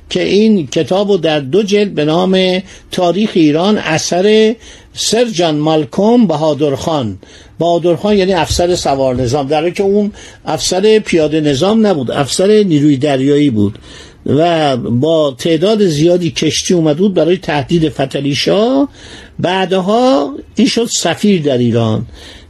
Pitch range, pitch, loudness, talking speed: 150-200 Hz, 170 Hz, -12 LUFS, 125 wpm